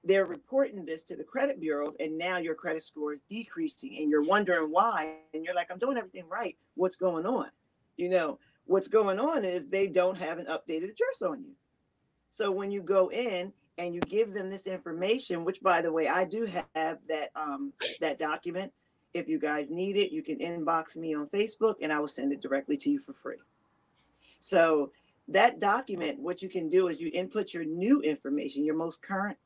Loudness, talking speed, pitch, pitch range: -30 LUFS, 205 wpm, 180 Hz, 160-200 Hz